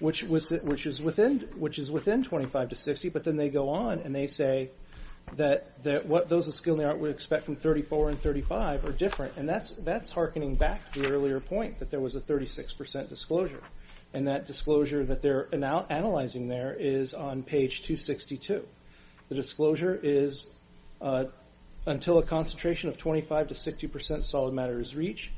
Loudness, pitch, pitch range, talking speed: -30 LUFS, 145 Hz, 135-155 Hz, 180 wpm